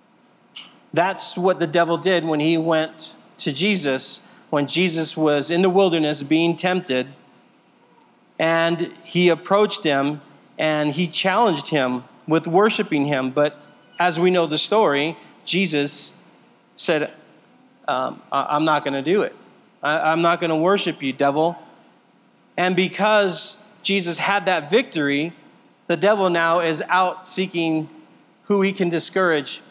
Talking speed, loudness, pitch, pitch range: 135 wpm, -20 LUFS, 170 Hz, 155-185 Hz